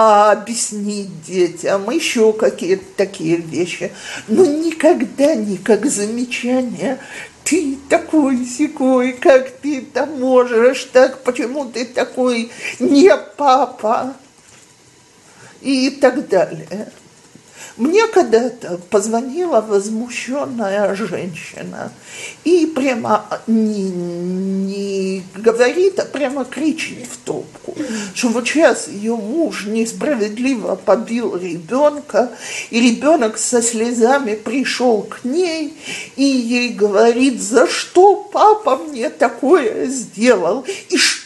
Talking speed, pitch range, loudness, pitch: 95 wpm, 215-280 Hz, -16 LUFS, 245 Hz